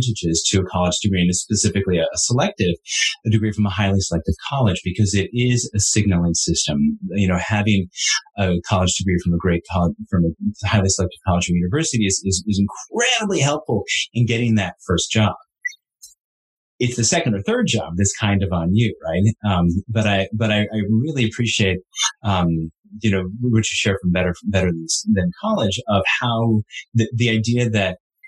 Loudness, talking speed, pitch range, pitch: -19 LUFS, 185 wpm, 90-115 Hz, 100 Hz